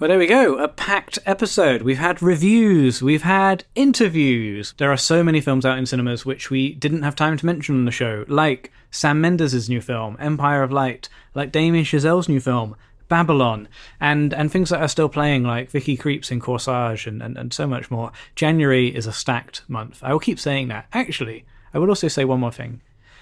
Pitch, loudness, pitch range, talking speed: 140 Hz, -19 LUFS, 125-155 Hz, 210 wpm